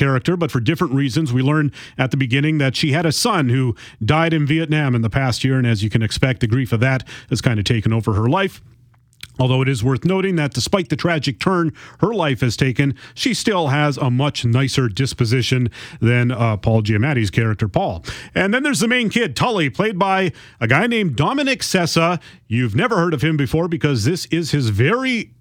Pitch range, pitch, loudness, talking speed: 125-165 Hz, 135 Hz, -18 LUFS, 215 wpm